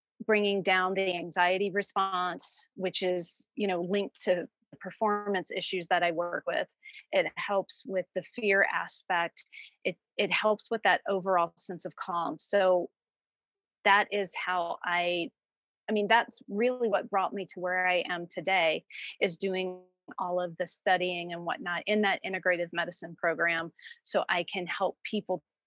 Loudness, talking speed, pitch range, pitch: -30 LUFS, 160 wpm, 180-205 Hz, 185 Hz